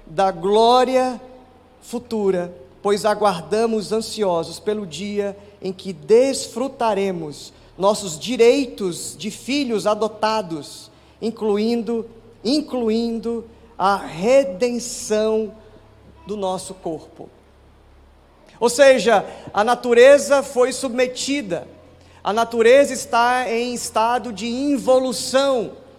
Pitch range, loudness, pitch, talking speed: 190-245 Hz, -19 LUFS, 220 Hz, 85 wpm